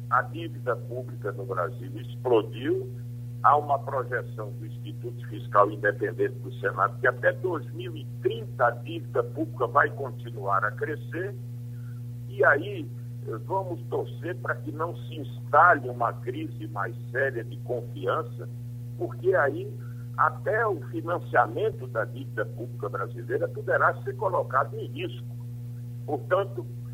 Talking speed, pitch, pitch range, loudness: 125 wpm, 120 Hz, 120-125 Hz, -28 LUFS